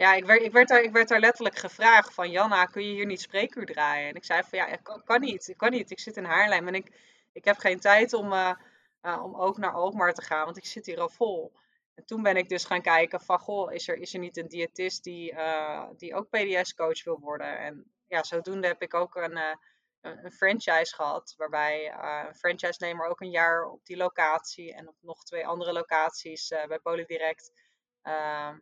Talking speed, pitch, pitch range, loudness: 225 wpm, 180 Hz, 165-205 Hz, -26 LUFS